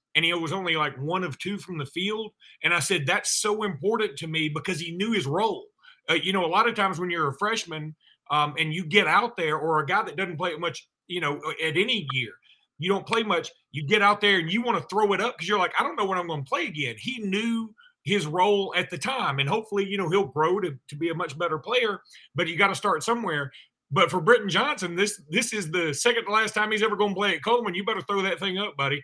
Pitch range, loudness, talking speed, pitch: 165-210 Hz, -25 LUFS, 275 wpm, 190 Hz